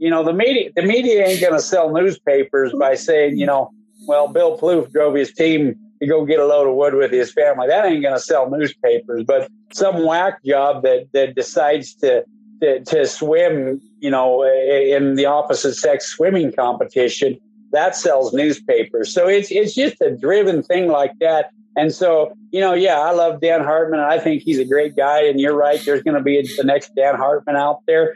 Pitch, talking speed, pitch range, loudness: 165 Hz, 200 wpm, 145-230 Hz, -17 LUFS